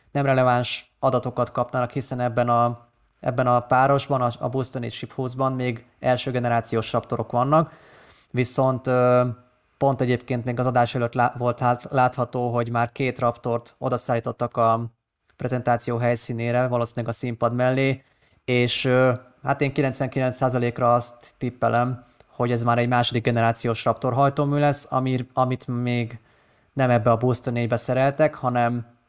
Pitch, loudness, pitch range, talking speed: 125 Hz, -23 LUFS, 120-130 Hz, 145 wpm